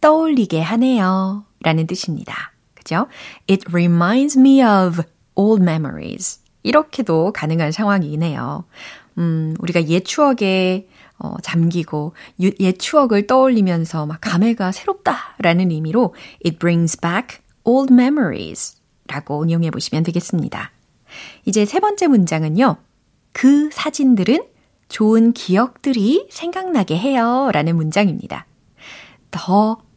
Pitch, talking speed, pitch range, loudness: 195 Hz, 310 characters per minute, 170-250 Hz, -17 LUFS